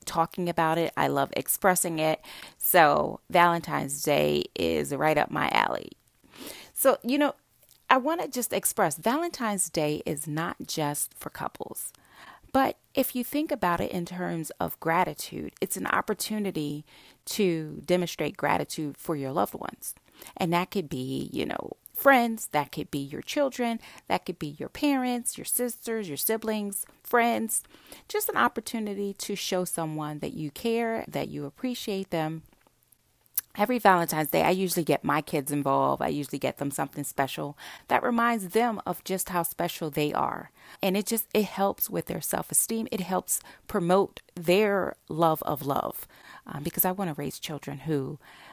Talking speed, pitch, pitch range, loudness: 165 wpm, 180 Hz, 150-225 Hz, -28 LUFS